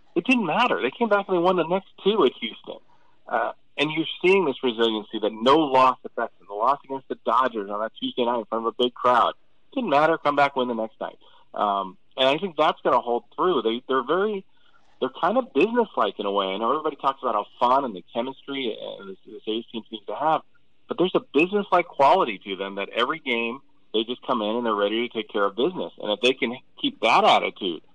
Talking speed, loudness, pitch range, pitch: 245 wpm, -23 LUFS, 110-160 Hz, 125 Hz